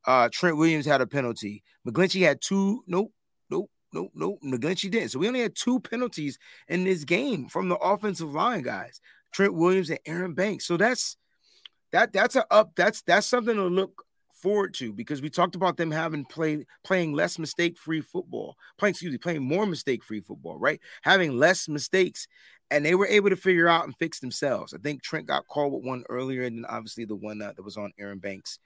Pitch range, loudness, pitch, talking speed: 140-190 Hz, -26 LUFS, 165 Hz, 205 wpm